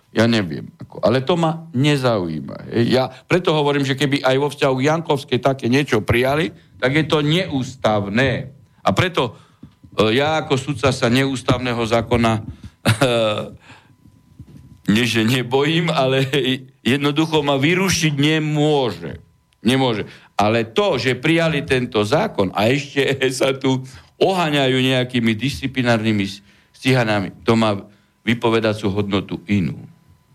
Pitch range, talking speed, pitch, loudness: 115-145 Hz, 115 wpm, 130 Hz, -18 LUFS